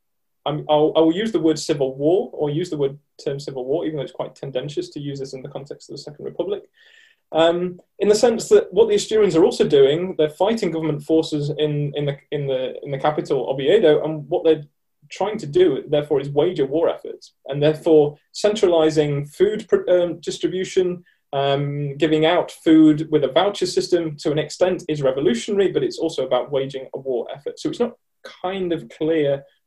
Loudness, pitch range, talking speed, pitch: -20 LUFS, 150-215 Hz, 205 wpm, 160 Hz